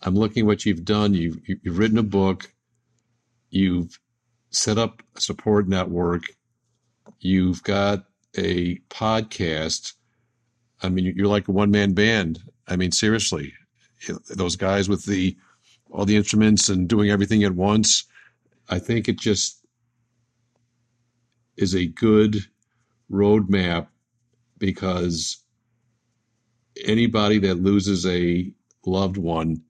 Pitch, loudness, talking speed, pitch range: 105 Hz, -22 LUFS, 120 wpm, 95-115 Hz